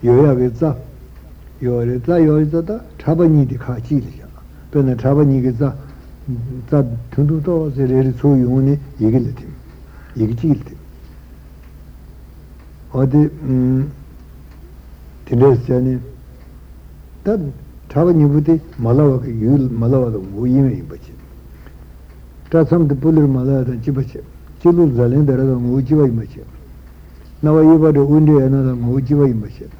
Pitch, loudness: 125 Hz, -15 LUFS